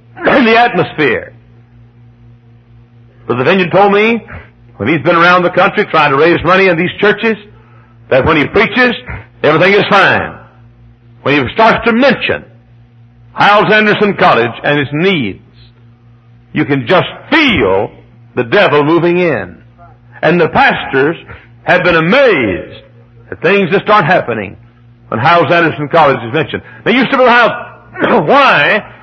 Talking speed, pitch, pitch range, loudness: 145 wpm, 140 Hz, 120-185 Hz, -10 LUFS